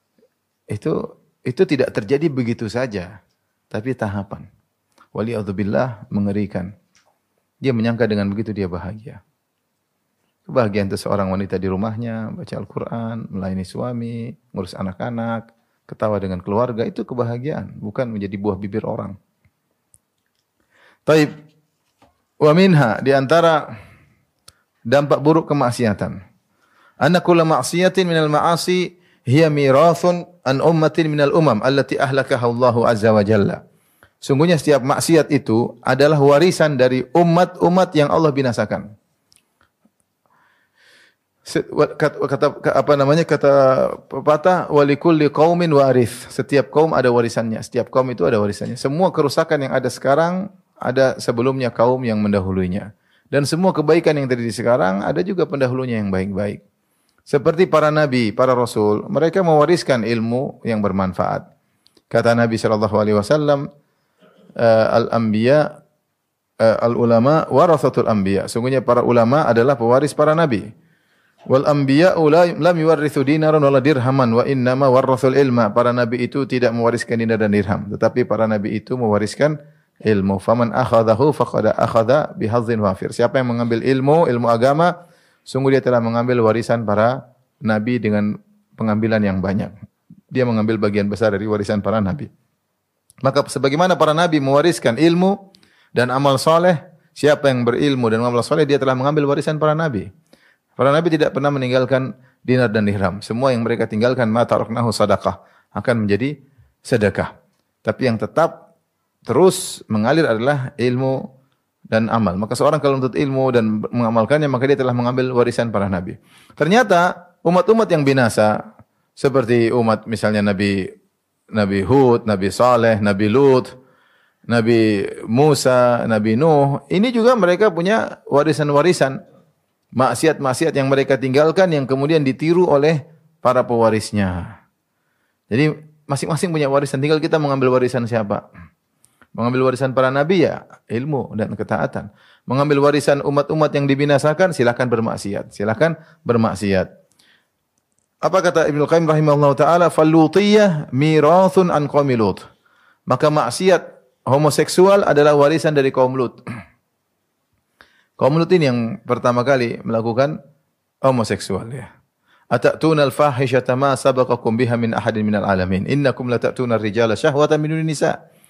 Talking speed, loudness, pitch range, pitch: 130 wpm, -17 LUFS, 115-150 Hz, 130 Hz